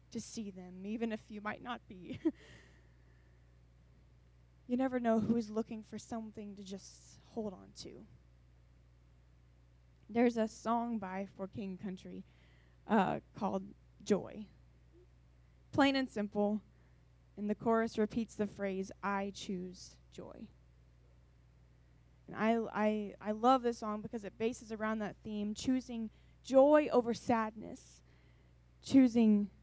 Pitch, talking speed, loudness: 200 Hz, 125 wpm, -35 LUFS